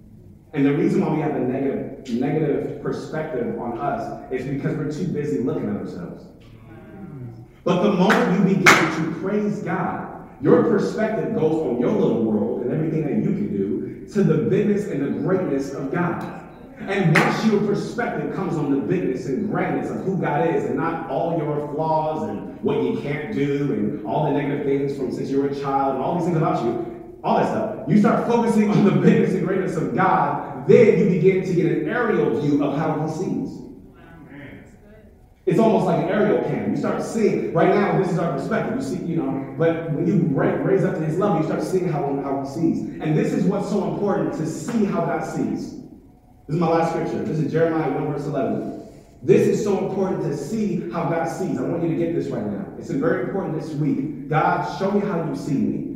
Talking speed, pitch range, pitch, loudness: 215 wpm, 145-195 Hz, 165 Hz, -21 LUFS